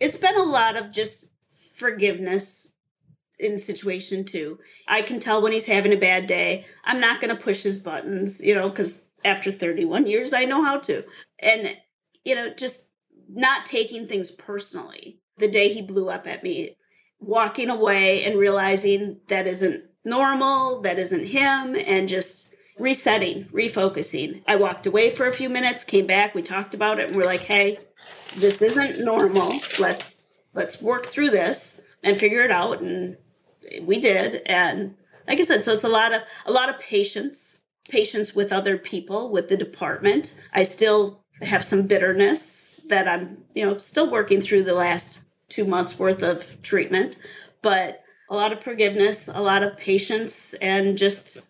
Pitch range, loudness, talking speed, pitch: 195-245 Hz, -22 LUFS, 170 wpm, 205 Hz